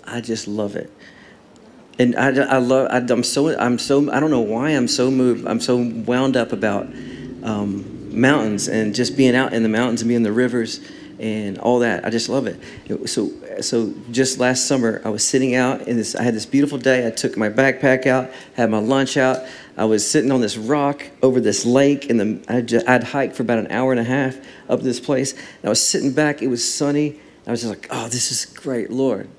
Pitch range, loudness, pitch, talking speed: 115-130 Hz, -19 LUFS, 125 Hz, 225 wpm